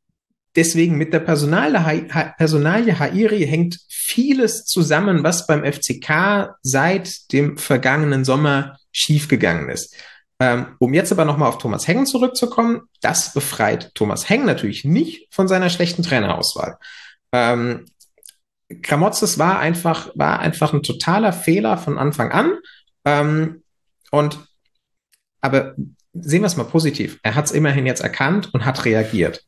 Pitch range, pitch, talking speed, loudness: 135-185 Hz, 155 Hz, 130 wpm, -18 LUFS